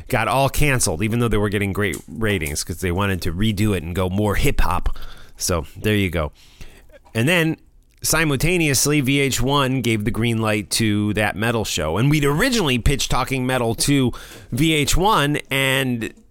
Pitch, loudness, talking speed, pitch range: 115 Hz, -20 LUFS, 170 wpm, 100-135 Hz